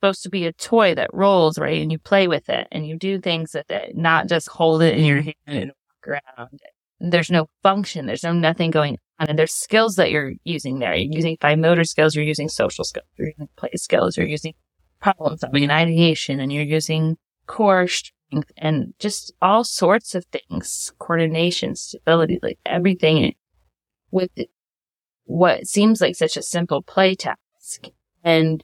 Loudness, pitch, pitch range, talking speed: -20 LUFS, 165 Hz, 155-185 Hz, 185 wpm